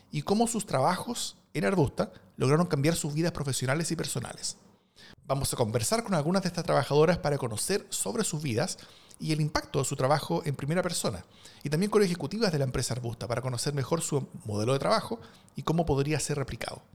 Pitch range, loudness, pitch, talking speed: 135-175 Hz, -29 LUFS, 150 Hz, 195 wpm